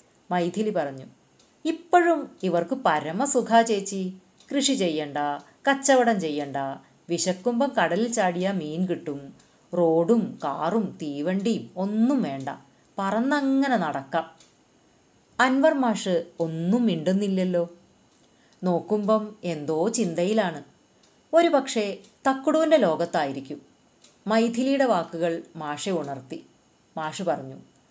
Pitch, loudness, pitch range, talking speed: 195 Hz, -25 LUFS, 165-235 Hz, 85 wpm